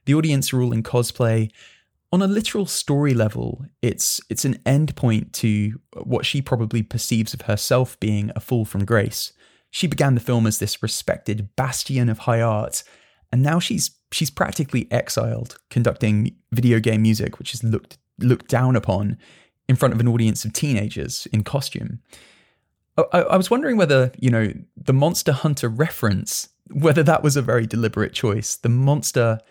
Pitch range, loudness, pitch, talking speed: 110-140 Hz, -21 LUFS, 120 Hz, 170 wpm